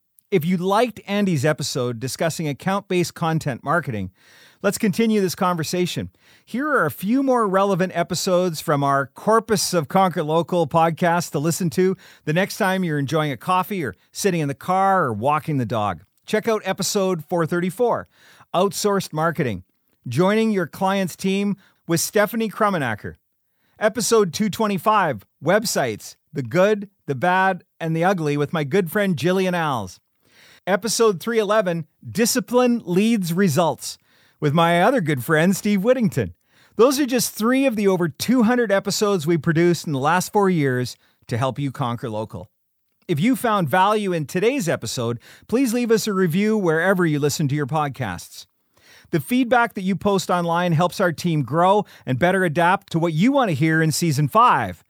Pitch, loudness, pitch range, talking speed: 175 Hz, -20 LUFS, 150-200 Hz, 165 wpm